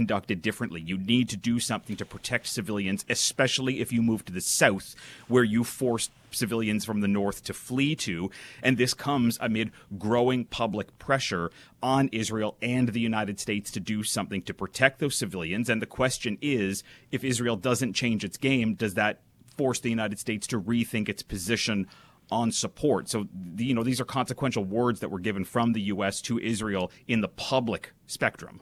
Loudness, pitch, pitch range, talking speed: -28 LUFS, 115 Hz, 105-125 Hz, 185 wpm